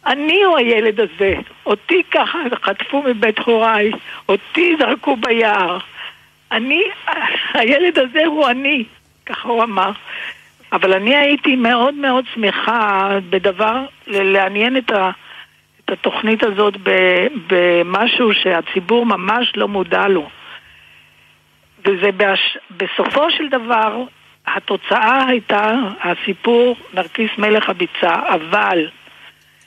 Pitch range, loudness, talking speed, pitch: 195-260 Hz, -15 LUFS, 105 wpm, 225 Hz